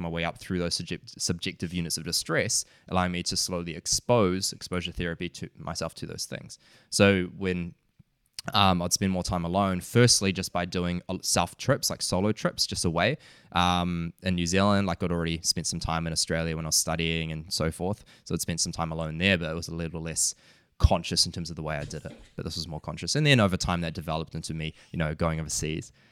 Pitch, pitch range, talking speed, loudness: 85 Hz, 80-95 Hz, 225 wpm, -27 LUFS